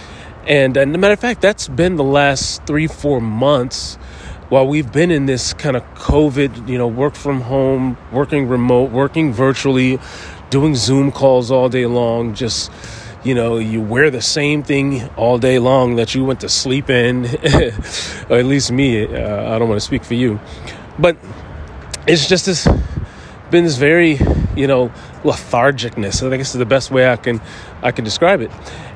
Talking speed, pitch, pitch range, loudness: 180 wpm, 130 Hz, 115-140 Hz, -15 LUFS